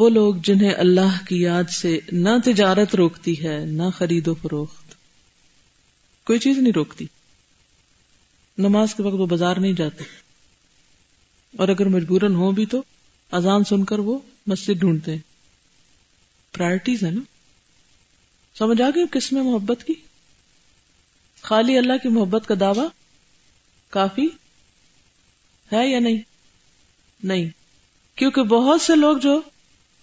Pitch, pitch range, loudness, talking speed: 200 Hz, 180-245 Hz, -20 LUFS, 130 wpm